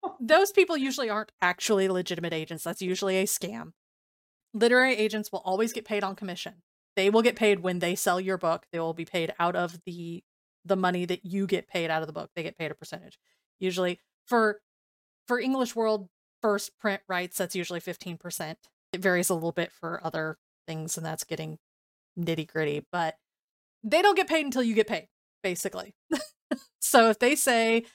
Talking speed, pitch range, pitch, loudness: 185 wpm, 170-220 Hz, 185 Hz, -27 LUFS